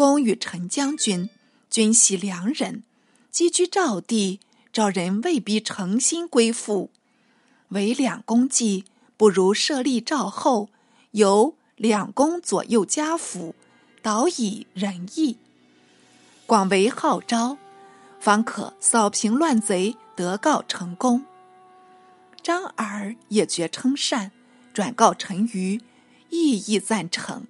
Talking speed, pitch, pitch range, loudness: 155 characters per minute, 225 Hz, 200-270 Hz, -22 LUFS